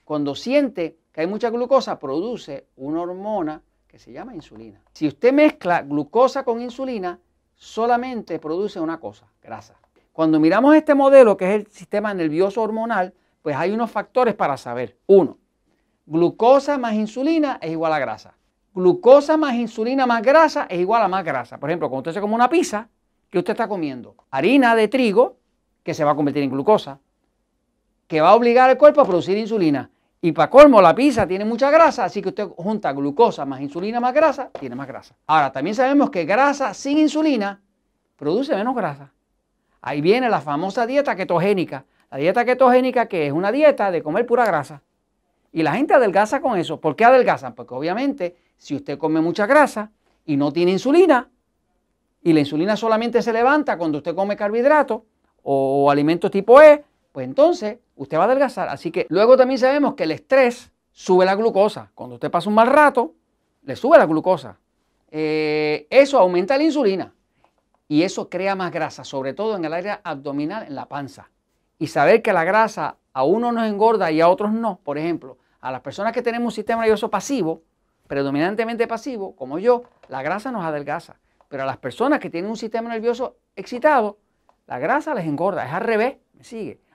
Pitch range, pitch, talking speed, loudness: 160-245 Hz, 205 Hz, 185 wpm, -18 LUFS